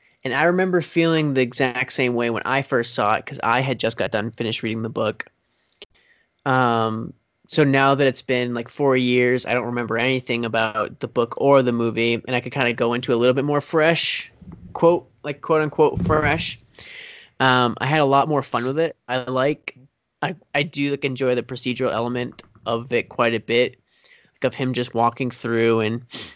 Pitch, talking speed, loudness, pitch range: 125 Hz, 205 wpm, -21 LUFS, 120-140 Hz